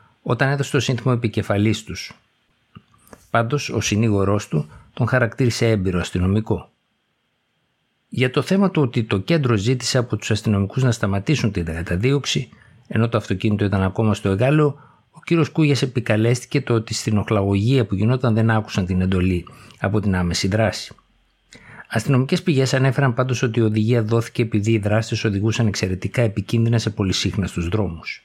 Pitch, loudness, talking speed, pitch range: 115 Hz, -20 LUFS, 150 wpm, 100-130 Hz